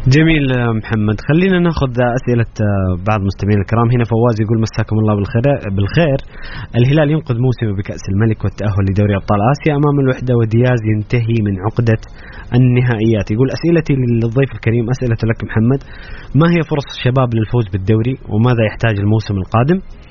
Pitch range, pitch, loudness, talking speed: 110-130 Hz, 115 Hz, -15 LUFS, 145 wpm